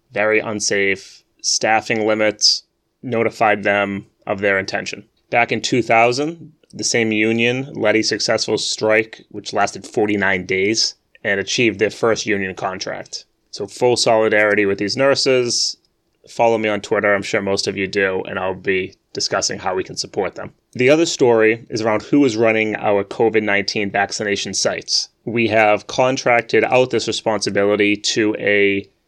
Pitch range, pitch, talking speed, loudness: 100-115 Hz, 110 Hz, 155 wpm, -17 LUFS